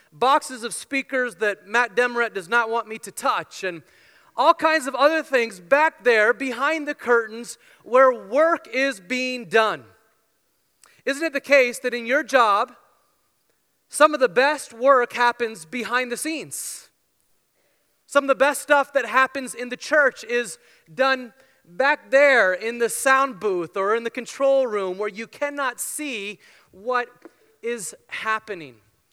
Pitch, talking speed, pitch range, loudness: 250 Hz, 155 wpm, 230-275 Hz, -21 LUFS